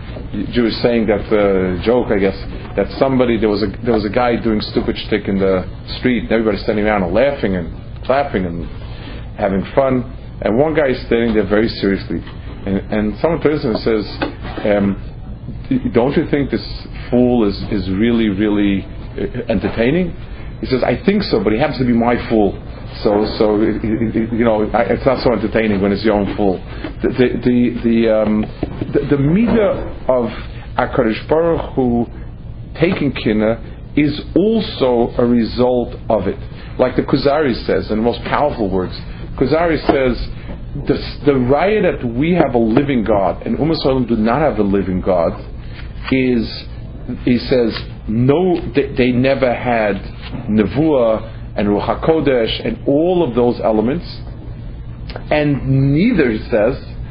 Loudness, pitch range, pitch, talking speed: -16 LUFS, 105-130 Hz, 115 Hz, 160 wpm